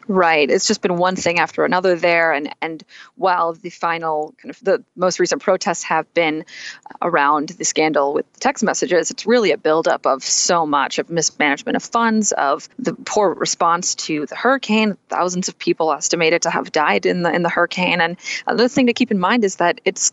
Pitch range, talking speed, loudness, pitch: 165-195 Hz, 205 wpm, -18 LUFS, 175 Hz